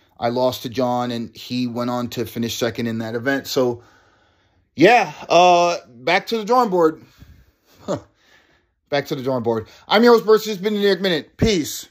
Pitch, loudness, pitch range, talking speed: 125 Hz, -19 LUFS, 115-175 Hz, 185 wpm